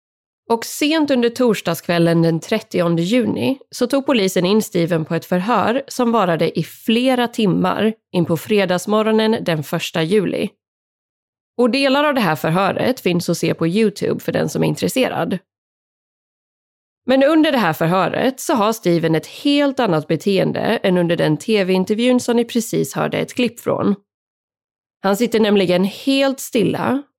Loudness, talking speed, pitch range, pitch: -18 LUFS, 155 wpm, 170-245 Hz, 205 Hz